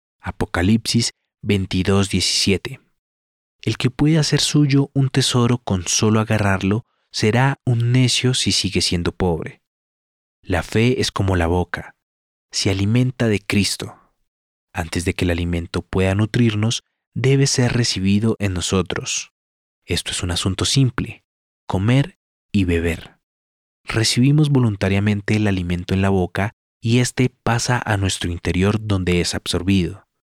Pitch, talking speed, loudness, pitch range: 100 Hz, 130 wpm, -19 LUFS, 90-120 Hz